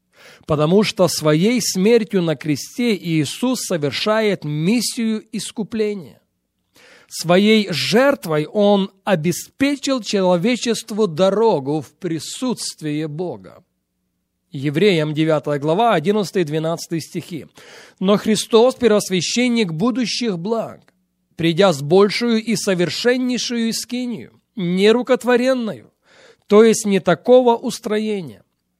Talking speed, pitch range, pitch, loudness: 85 wpm, 165-230 Hz, 205 Hz, -18 LUFS